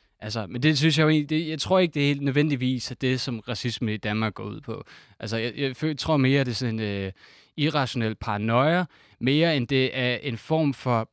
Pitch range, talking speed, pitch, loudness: 115-150 Hz, 225 wpm, 130 Hz, -25 LUFS